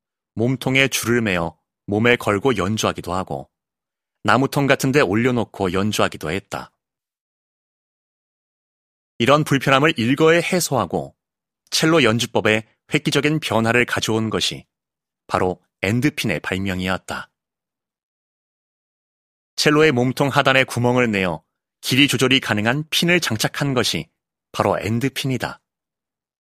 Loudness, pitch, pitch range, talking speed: -19 LUFS, 120 Hz, 105-140 Hz, 255 characters per minute